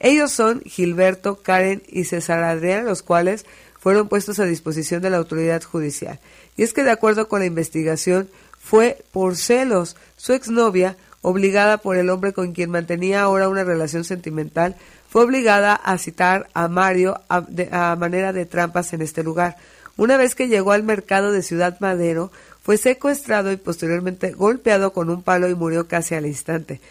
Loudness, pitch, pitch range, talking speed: -19 LUFS, 185 Hz, 170-205 Hz, 175 wpm